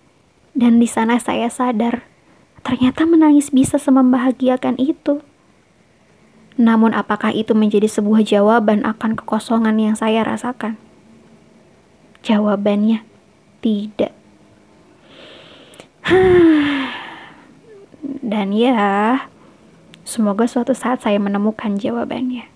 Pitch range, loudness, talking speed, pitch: 215-260 Hz, -16 LUFS, 80 wpm, 235 Hz